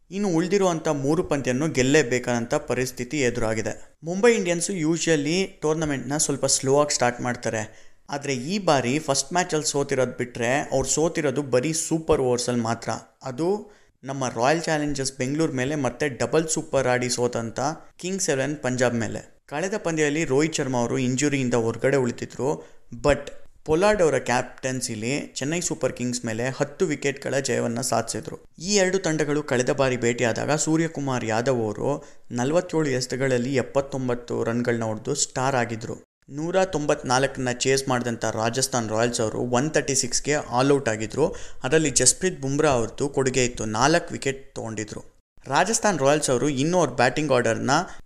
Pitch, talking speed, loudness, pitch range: 135 Hz, 135 wpm, -24 LUFS, 120-155 Hz